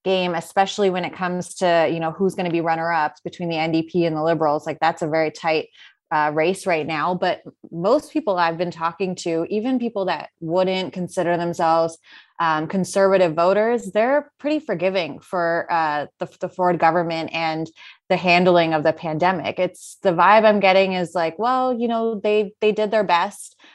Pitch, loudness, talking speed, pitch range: 180 Hz, -20 LUFS, 185 wpm, 165-195 Hz